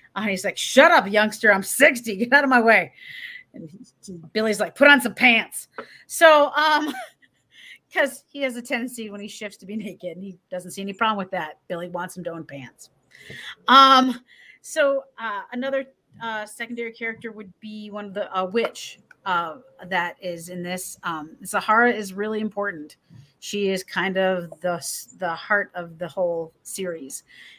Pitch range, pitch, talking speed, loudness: 180-245 Hz, 210 Hz, 180 wpm, -21 LUFS